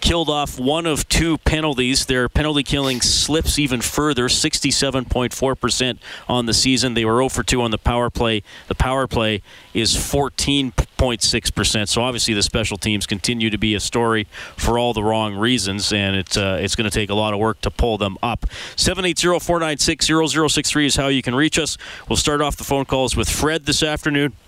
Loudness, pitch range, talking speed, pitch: -18 LUFS, 110-145 Hz, 195 wpm, 125 Hz